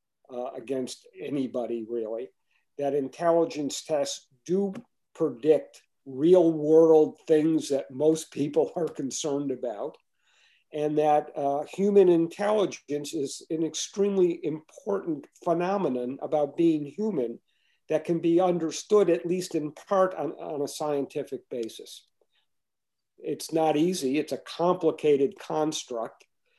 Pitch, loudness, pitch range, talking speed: 155 Hz, -27 LUFS, 140-175 Hz, 115 wpm